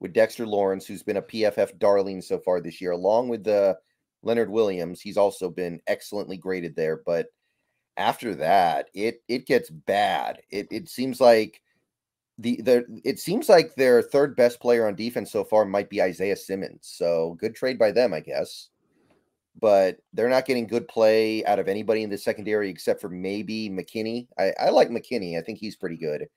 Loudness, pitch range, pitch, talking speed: -24 LUFS, 95-115 Hz, 105 Hz, 190 wpm